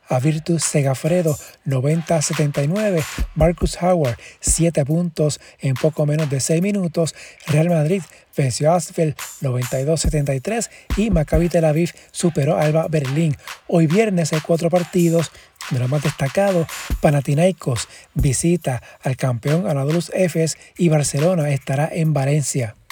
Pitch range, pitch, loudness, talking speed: 145-170 Hz, 160 Hz, -19 LUFS, 125 wpm